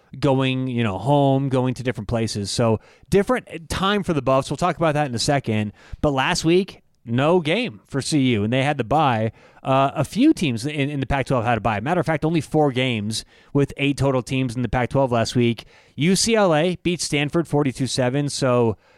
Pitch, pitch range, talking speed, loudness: 135 Hz, 125-155 Hz, 215 wpm, -21 LUFS